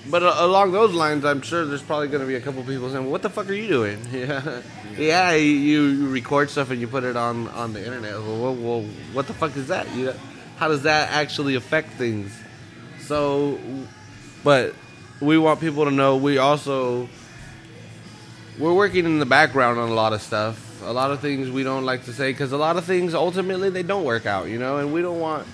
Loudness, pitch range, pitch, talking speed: -22 LUFS, 120-155 Hz, 140 Hz, 220 wpm